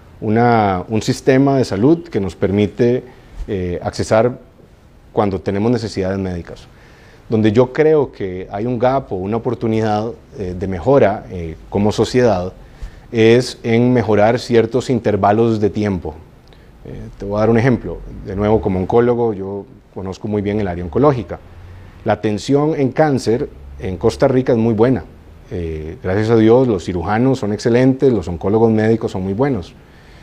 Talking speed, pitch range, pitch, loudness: 155 wpm, 95-120 Hz, 110 Hz, -16 LUFS